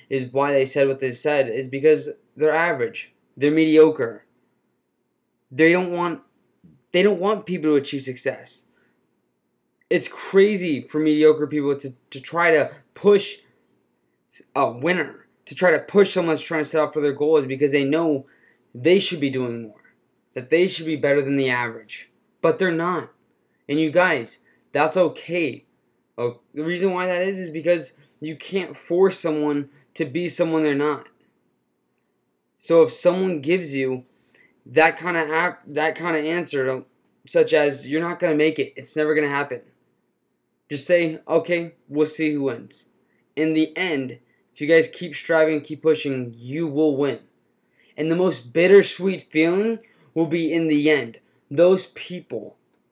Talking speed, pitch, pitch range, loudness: 165 wpm, 155 Hz, 140-175 Hz, -21 LUFS